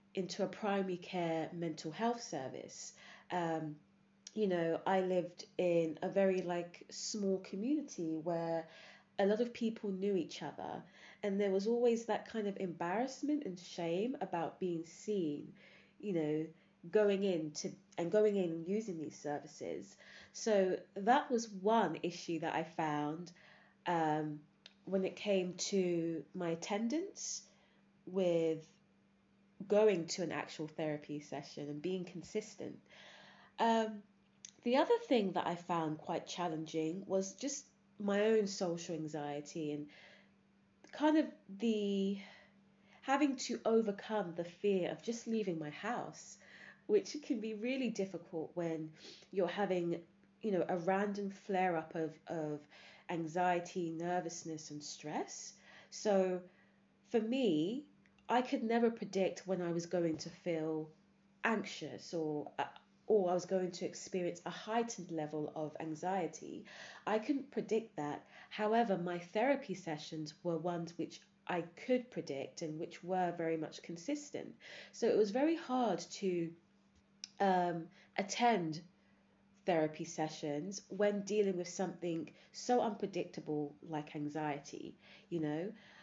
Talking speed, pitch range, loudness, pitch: 135 wpm, 165-205 Hz, -38 LUFS, 185 Hz